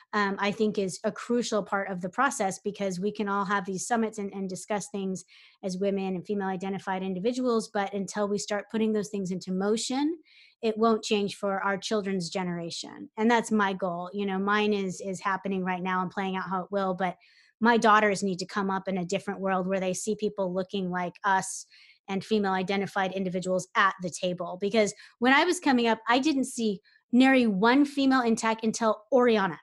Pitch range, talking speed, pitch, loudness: 190-220 Hz, 205 wpm, 200 Hz, -28 LUFS